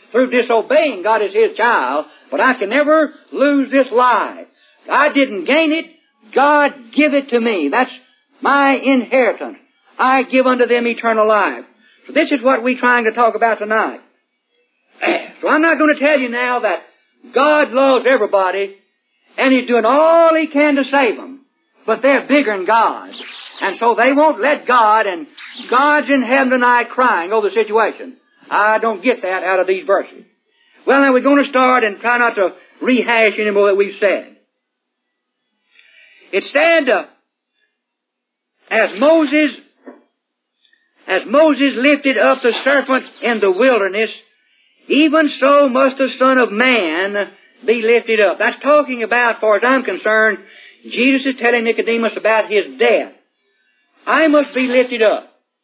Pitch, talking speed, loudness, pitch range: 255 Hz, 160 wpm, -14 LUFS, 225-290 Hz